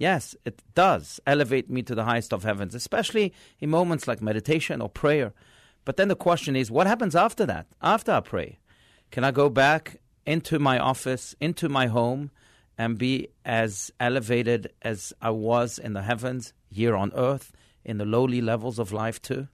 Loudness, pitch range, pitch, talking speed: -25 LUFS, 115-140 Hz, 125 Hz, 180 wpm